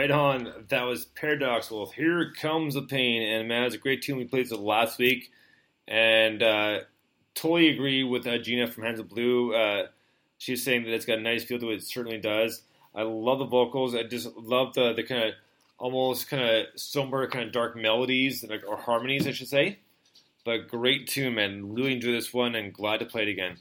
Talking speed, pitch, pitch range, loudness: 210 wpm, 120 Hz, 115-130 Hz, -27 LUFS